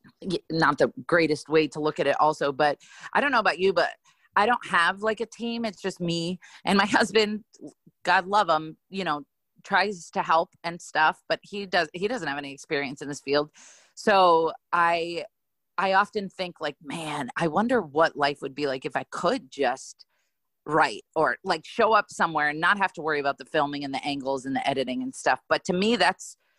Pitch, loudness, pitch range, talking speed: 170 Hz, -25 LUFS, 150-200 Hz, 210 wpm